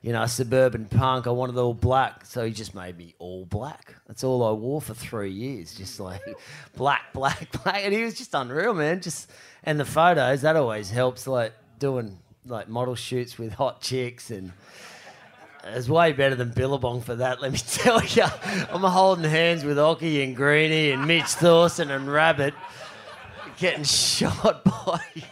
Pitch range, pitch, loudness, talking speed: 115-150 Hz, 130 Hz, -23 LUFS, 180 wpm